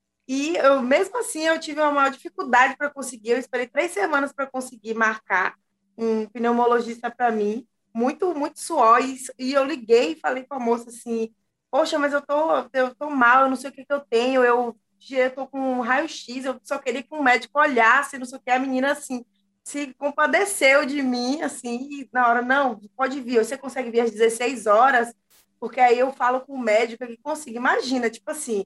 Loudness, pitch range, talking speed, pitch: -22 LUFS, 235-280 Hz, 205 wpm, 255 Hz